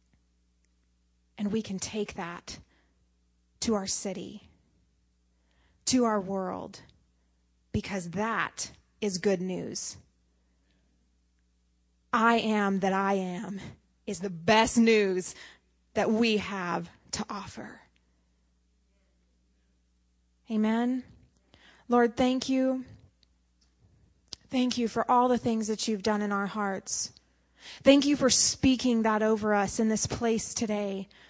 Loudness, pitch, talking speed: -28 LUFS, 195 Hz, 110 wpm